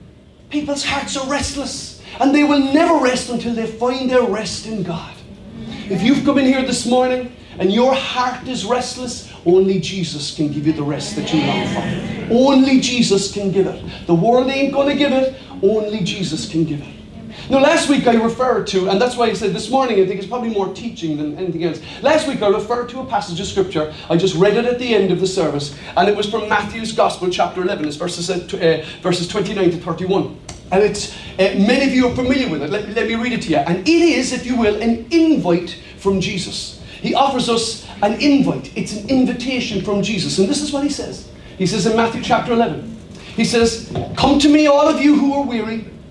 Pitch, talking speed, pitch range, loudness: 225 Hz, 225 wpm, 190-255 Hz, -17 LUFS